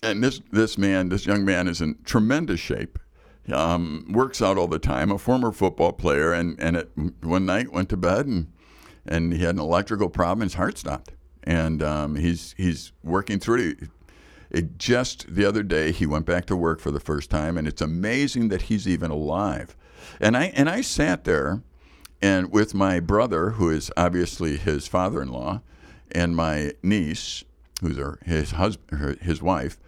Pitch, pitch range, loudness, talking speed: 85 Hz, 80-100 Hz, -24 LUFS, 185 wpm